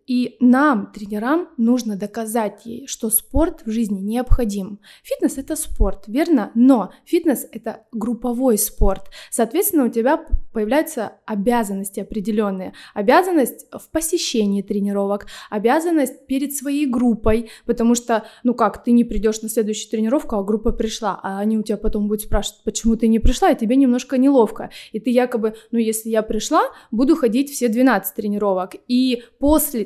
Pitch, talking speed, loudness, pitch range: 230 Hz, 155 wpm, -20 LUFS, 215-265 Hz